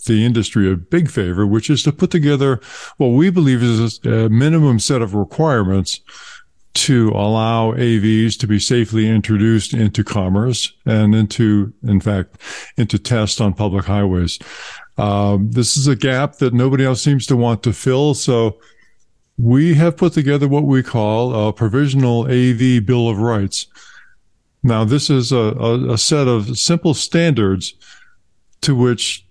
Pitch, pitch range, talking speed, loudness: 120 Hz, 105-135 Hz, 155 wpm, -15 LUFS